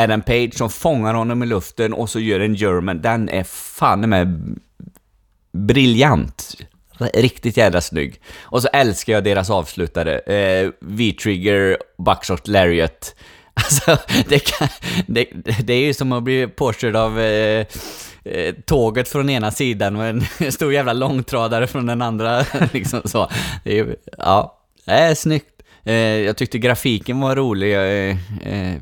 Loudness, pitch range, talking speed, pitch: -18 LUFS, 100-125 Hz, 150 wpm, 115 Hz